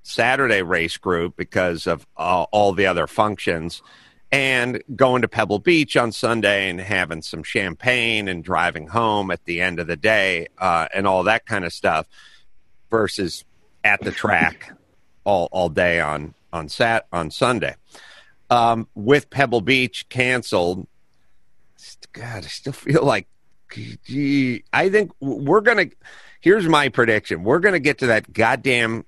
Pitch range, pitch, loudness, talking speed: 90-125 Hz, 110 Hz, -19 LUFS, 155 wpm